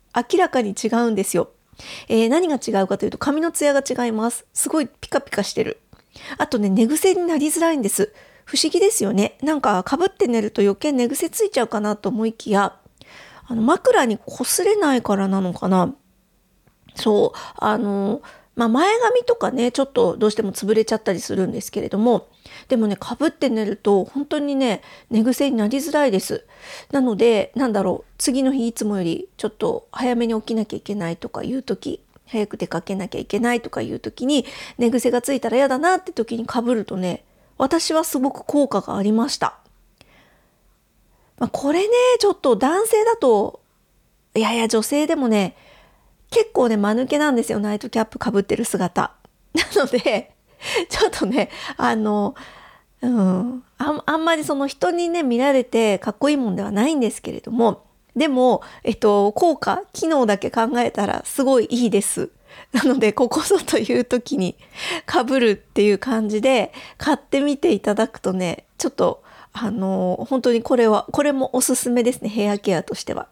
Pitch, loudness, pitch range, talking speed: 245 Hz, -20 LUFS, 215-290 Hz, 345 characters per minute